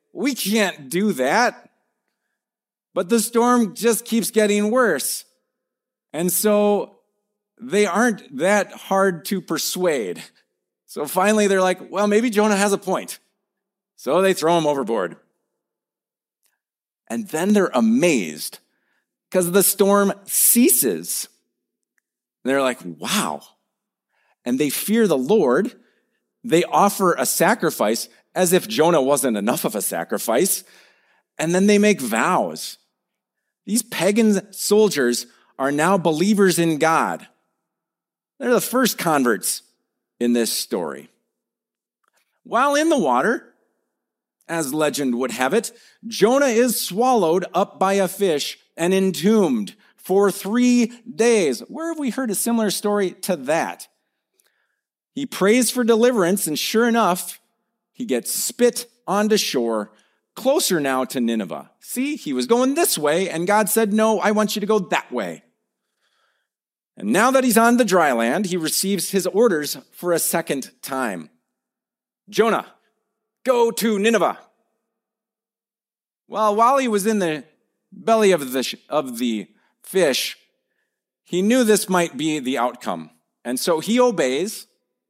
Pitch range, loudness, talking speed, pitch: 175-230 Hz, -19 LUFS, 130 wpm, 205 Hz